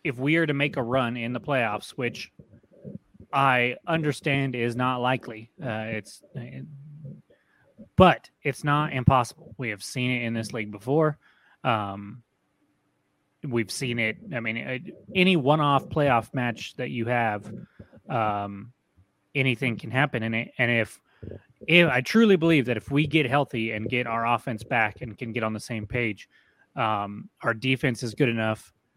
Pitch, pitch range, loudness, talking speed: 120 Hz, 110-140 Hz, -25 LUFS, 165 wpm